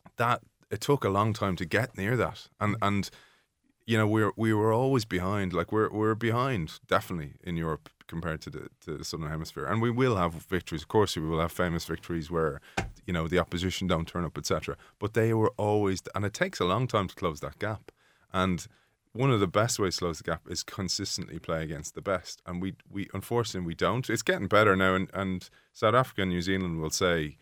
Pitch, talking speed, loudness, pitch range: 95 Hz, 225 wpm, -29 LUFS, 85-110 Hz